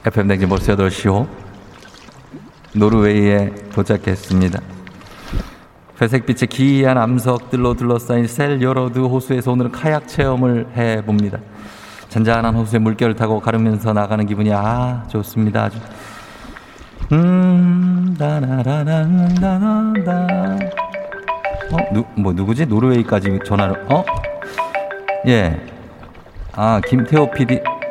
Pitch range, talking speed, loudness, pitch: 105-140 Hz, 245 characters per minute, -17 LUFS, 115 Hz